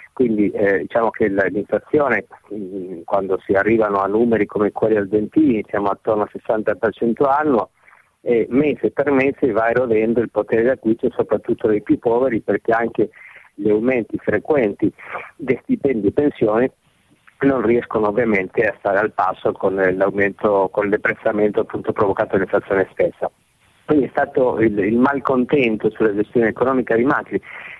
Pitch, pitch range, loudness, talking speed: 110 Hz, 105-130 Hz, -18 LUFS, 145 wpm